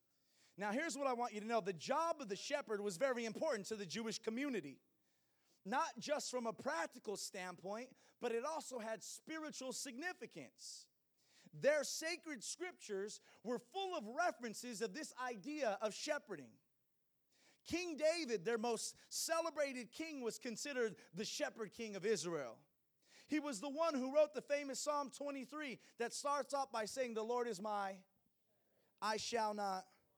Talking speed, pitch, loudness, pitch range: 155 wpm, 245 Hz, -43 LUFS, 220-295 Hz